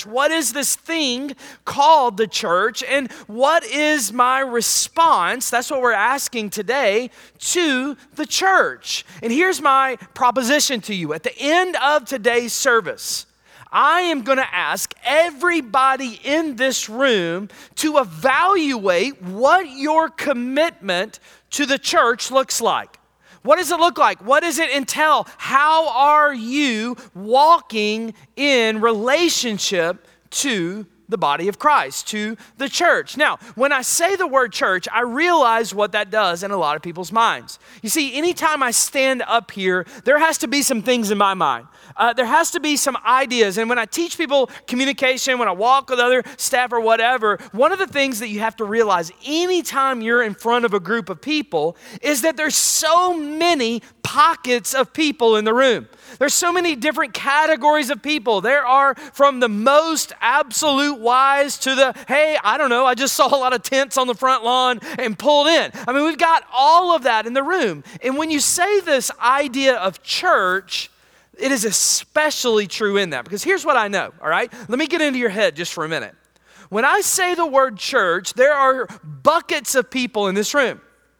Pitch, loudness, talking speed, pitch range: 265 Hz, -18 LUFS, 185 wpm, 230-300 Hz